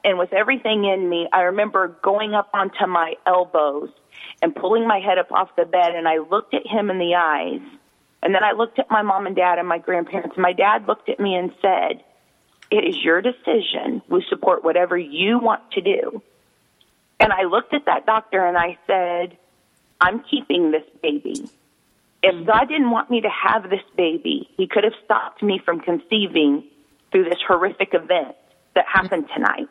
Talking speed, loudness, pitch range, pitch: 190 wpm, -20 LUFS, 175-225 Hz, 190 Hz